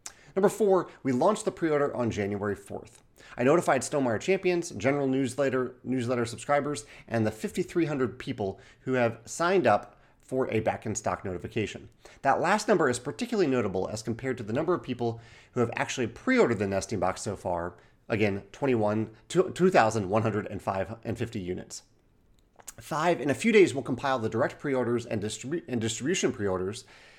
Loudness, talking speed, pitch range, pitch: -28 LUFS, 155 wpm, 110-145 Hz, 120 Hz